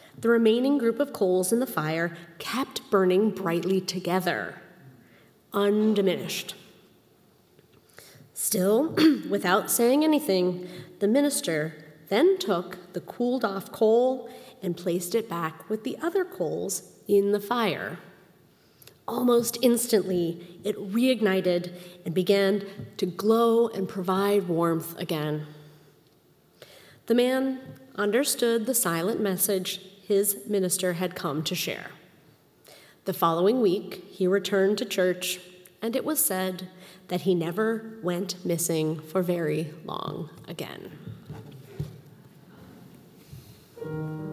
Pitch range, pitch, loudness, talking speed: 170-220 Hz, 190 Hz, -26 LUFS, 110 wpm